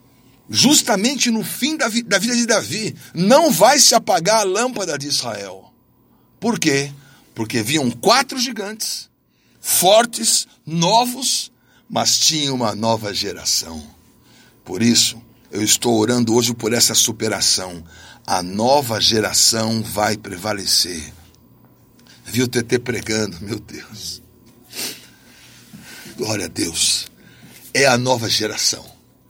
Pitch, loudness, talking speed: 125 Hz, -17 LUFS, 115 wpm